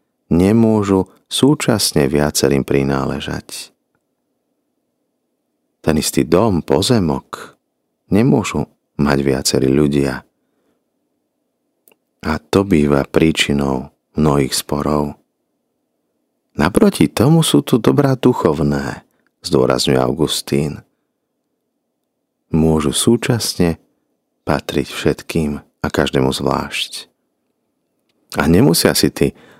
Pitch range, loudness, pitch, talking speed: 70-95 Hz, -16 LUFS, 75 Hz, 75 wpm